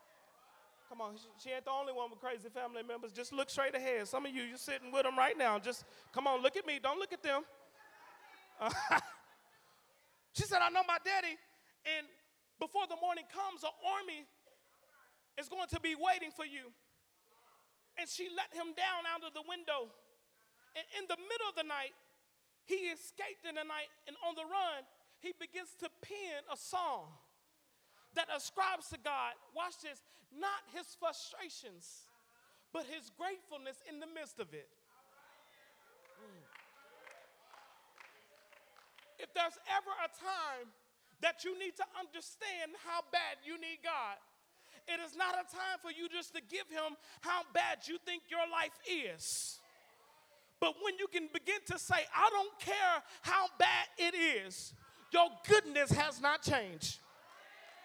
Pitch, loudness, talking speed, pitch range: 335 Hz, -38 LUFS, 160 wpm, 285-370 Hz